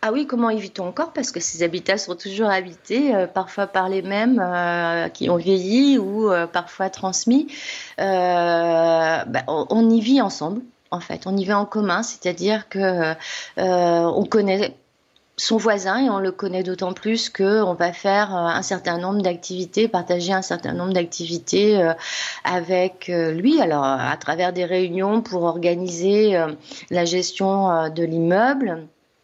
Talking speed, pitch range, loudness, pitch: 165 wpm, 175-210 Hz, -21 LUFS, 185 Hz